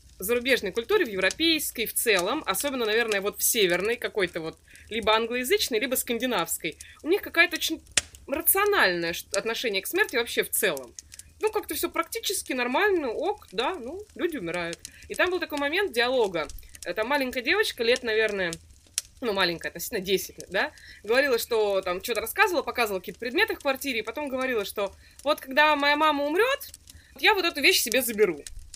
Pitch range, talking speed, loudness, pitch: 215-355 Hz, 170 wpm, -25 LUFS, 260 Hz